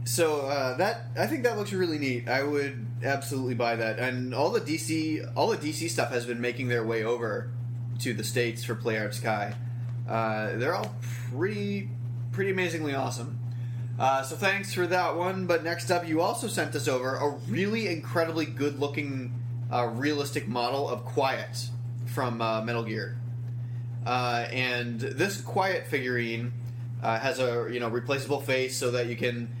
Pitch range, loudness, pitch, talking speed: 120-135 Hz, -29 LUFS, 120 Hz, 170 wpm